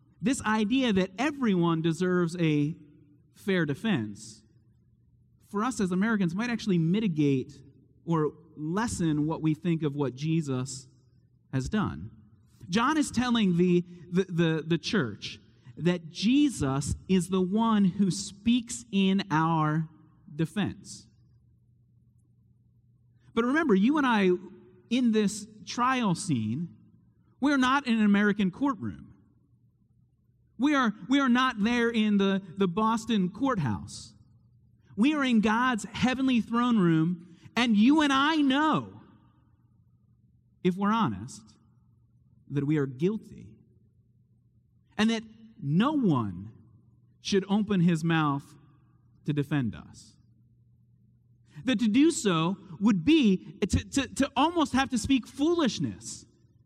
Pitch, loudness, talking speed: 170 Hz, -27 LUFS, 120 wpm